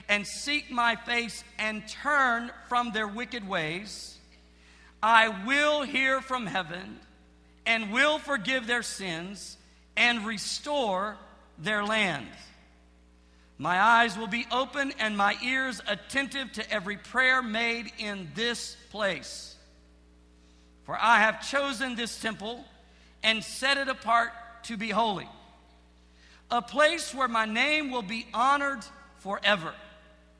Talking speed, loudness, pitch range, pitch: 120 wpm, -27 LUFS, 180-245 Hz, 220 Hz